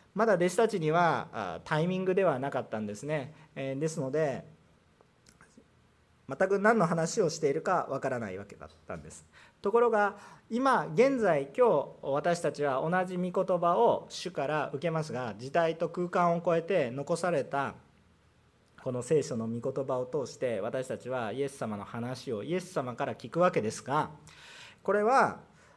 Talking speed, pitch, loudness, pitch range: 305 characters per minute, 165 Hz, -30 LUFS, 135-185 Hz